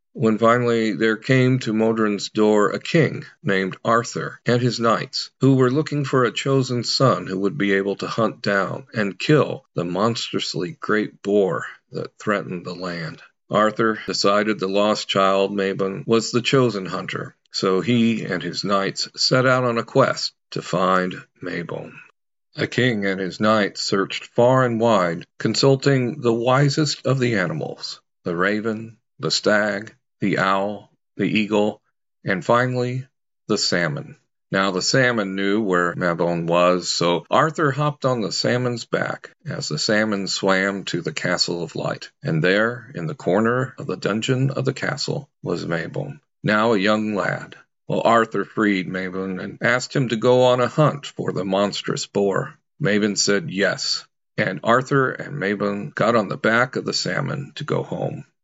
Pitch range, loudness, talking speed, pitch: 95-125 Hz, -21 LUFS, 165 wpm, 110 Hz